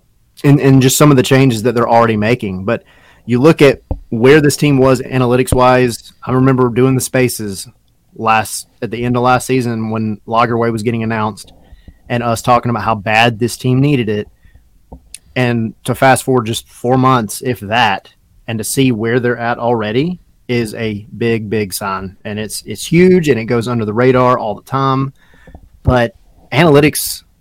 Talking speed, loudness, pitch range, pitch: 180 wpm, -13 LUFS, 110-130 Hz, 120 Hz